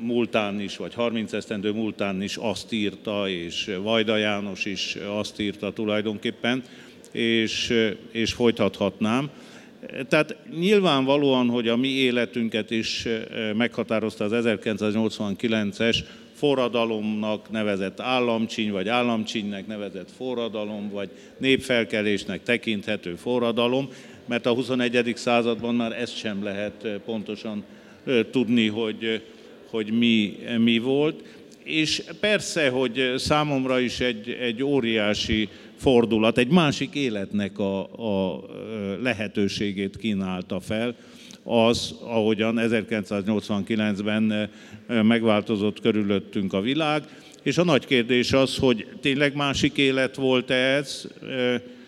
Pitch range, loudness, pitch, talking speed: 105-125 Hz, -24 LUFS, 115 Hz, 105 wpm